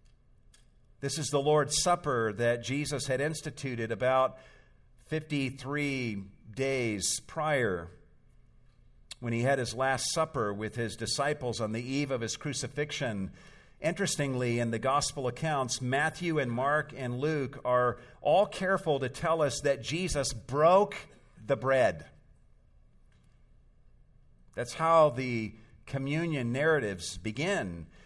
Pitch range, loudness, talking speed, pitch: 120-150 Hz, -30 LUFS, 120 wpm, 135 Hz